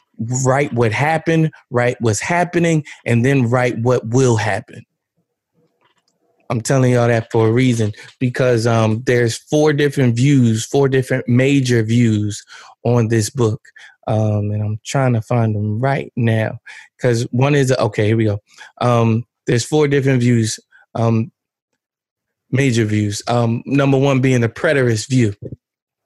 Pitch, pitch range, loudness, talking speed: 120 Hz, 115-135 Hz, -16 LUFS, 145 wpm